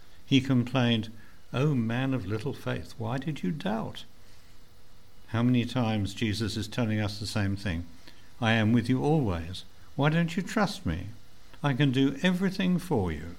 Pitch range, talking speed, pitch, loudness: 100-135 Hz, 170 wpm, 115 Hz, -29 LUFS